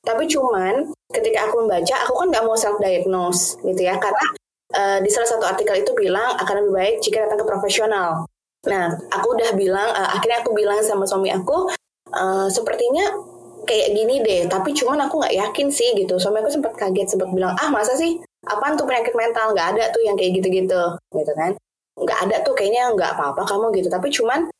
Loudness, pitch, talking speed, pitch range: -19 LUFS, 220 Hz, 200 wpm, 195-310 Hz